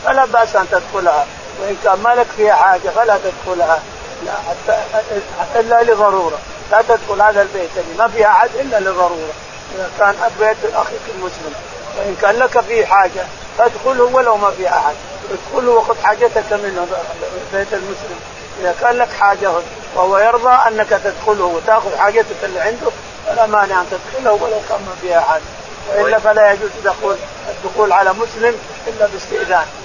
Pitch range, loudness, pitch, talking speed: 195-230 Hz, -14 LUFS, 210 Hz, 155 wpm